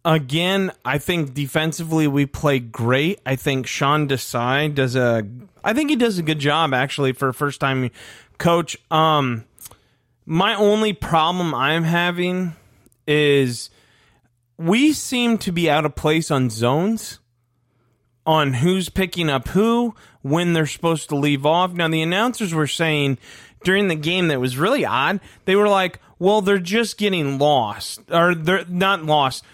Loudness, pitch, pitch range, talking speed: -19 LUFS, 155 Hz, 130-180 Hz, 155 wpm